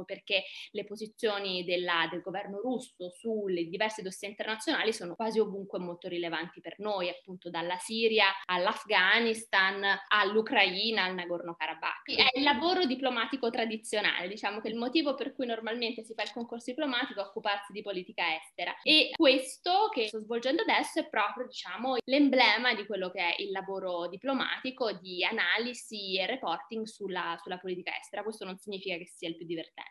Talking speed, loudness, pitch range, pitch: 160 wpm, -30 LUFS, 185-235 Hz, 210 Hz